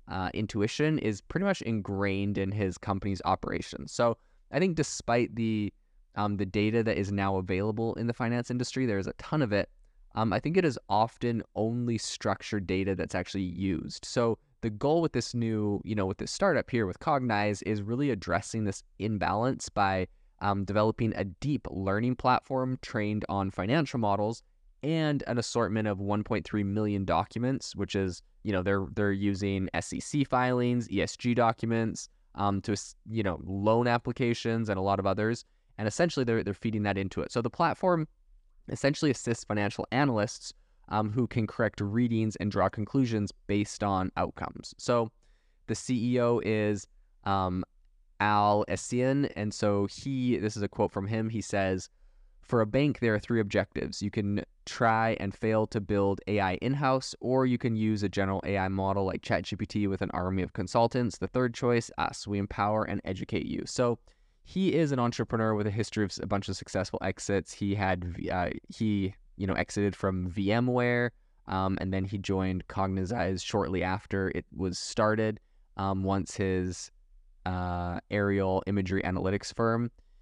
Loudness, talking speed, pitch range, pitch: -30 LUFS, 170 wpm, 95-115 Hz, 105 Hz